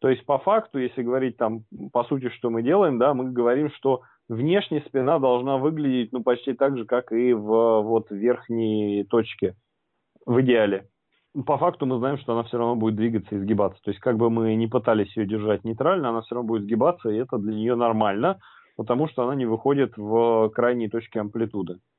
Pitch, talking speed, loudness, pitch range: 120 Hz, 200 wpm, -24 LUFS, 110-130 Hz